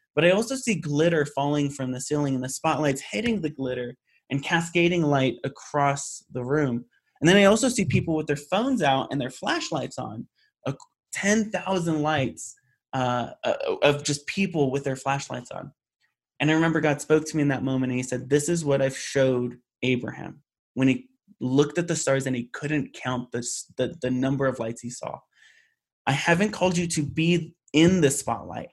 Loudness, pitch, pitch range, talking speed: -25 LUFS, 145 Hz, 130-170 Hz, 190 wpm